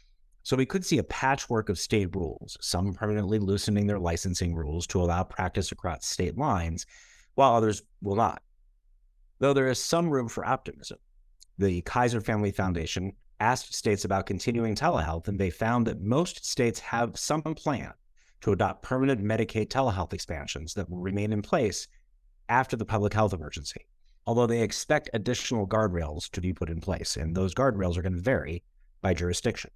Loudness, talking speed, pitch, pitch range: -28 LUFS, 170 wpm, 105 Hz, 90-115 Hz